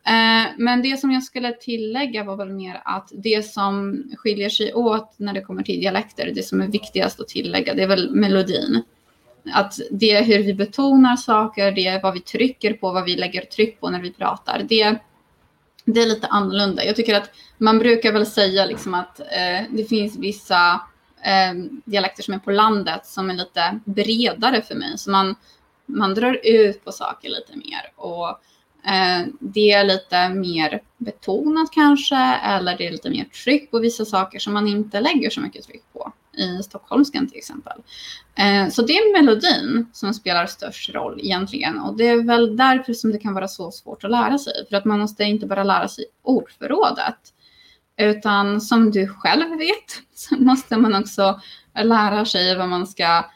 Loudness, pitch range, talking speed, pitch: -19 LUFS, 195-235 Hz, 185 wpm, 215 Hz